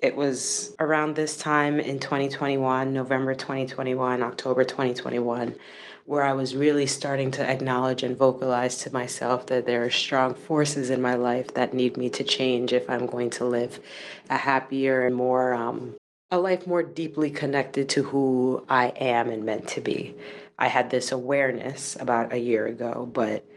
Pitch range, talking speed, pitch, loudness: 125-140 Hz, 170 wpm, 130 Hz, -25 LUFS